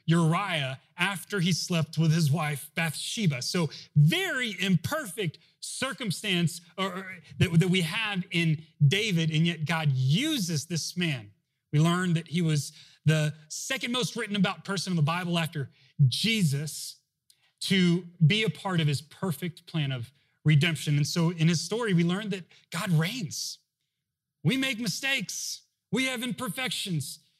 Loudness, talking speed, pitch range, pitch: -28 LUFS, 140 wpm, 150-185 Hz, 165 Hz